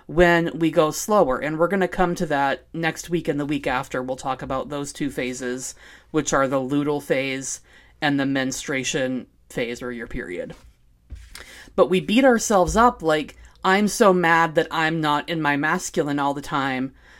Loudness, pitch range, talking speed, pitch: -22 LUFS, 130-170 Hz, 185 wpm, 145 Hz